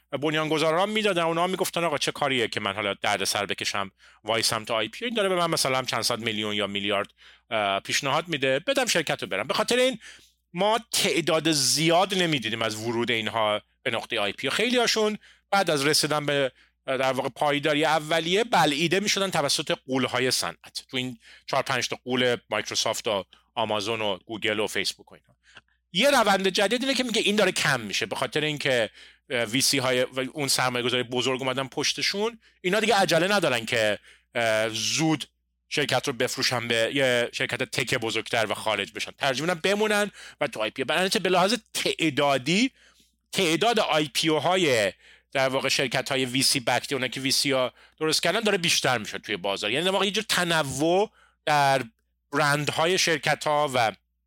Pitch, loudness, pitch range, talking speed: 140 Hz, -24 LUFS, 120-170 Hz, 180 wpm